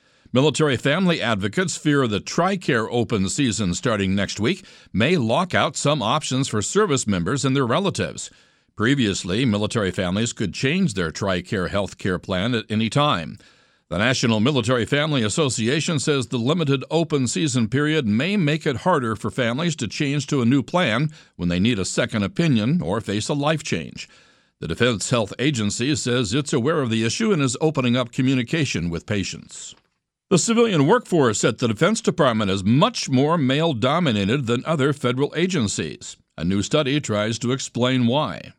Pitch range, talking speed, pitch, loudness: 115-155 Hz, 170 wpm, 135 Hz, -21 LUFS